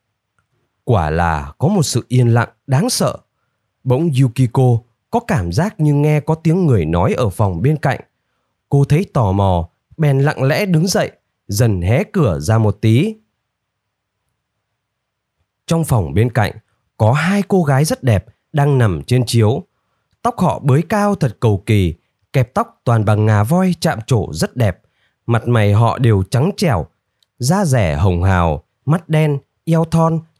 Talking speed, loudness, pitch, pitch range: 165 wpm, -16 LUFS, 125 Hz, 105-155 Hz